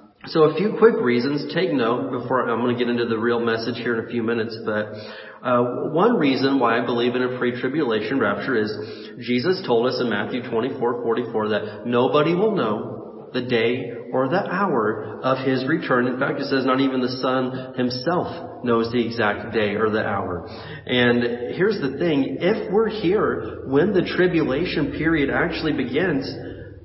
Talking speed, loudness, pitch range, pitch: 180 wpm, -22 LUFS, 120-135 Hz, 125 Hz